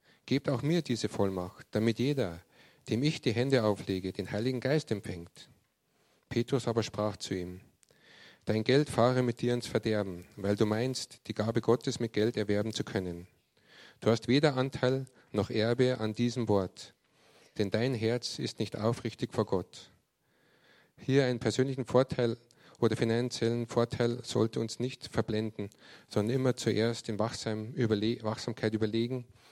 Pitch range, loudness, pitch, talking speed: 105-125 Hz, -31 LUFS, 115 Hz, 150 wpm